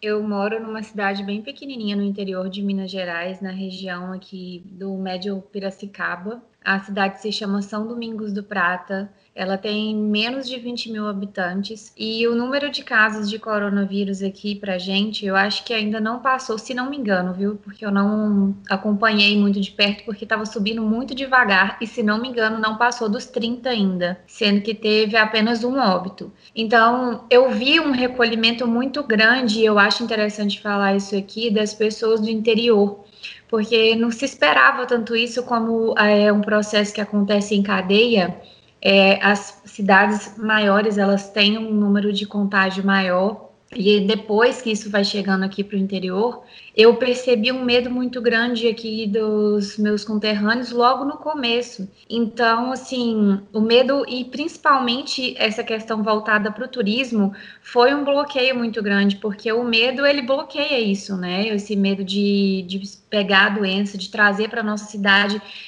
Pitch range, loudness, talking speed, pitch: 200-235 Hz, -19 LUFS, 165 wpm, 215 Hz